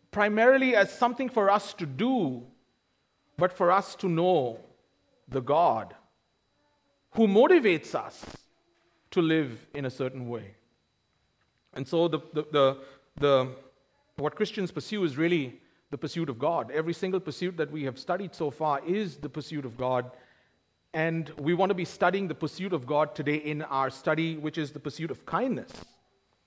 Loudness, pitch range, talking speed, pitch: -28 LUFS, 145-185 Hz, 165 wpm, 160 Hz